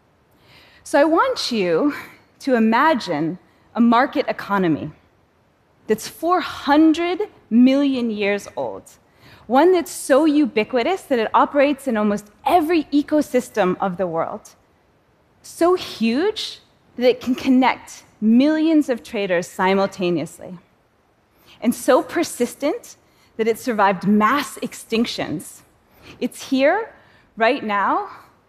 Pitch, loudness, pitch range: 250 Hz, -19 LUFS, 210-300 Hz